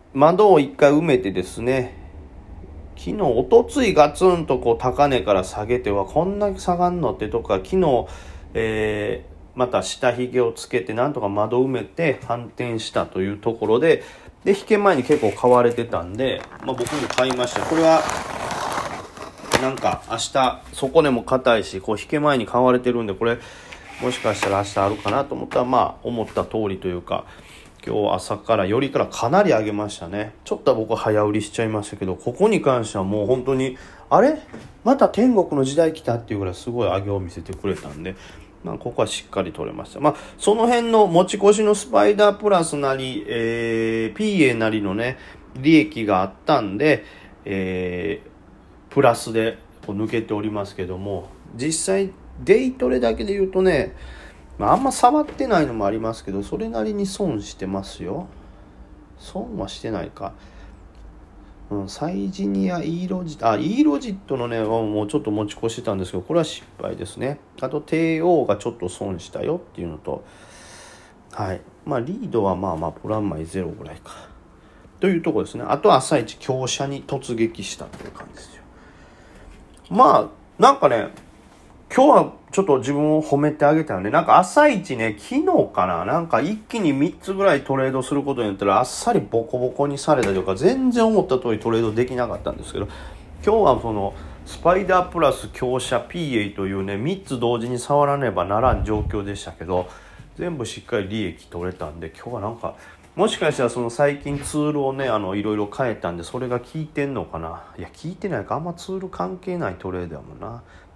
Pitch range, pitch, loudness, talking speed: 100-155 Hz, 120 Hz, -21 LUFS, 365 characters per minute